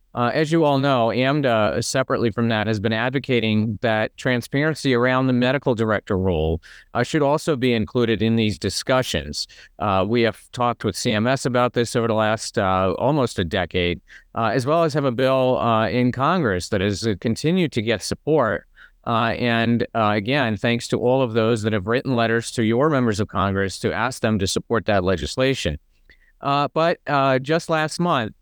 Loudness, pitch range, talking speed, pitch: -21 LUFS, 110-130 Hz, 190 wpm, 115 Hz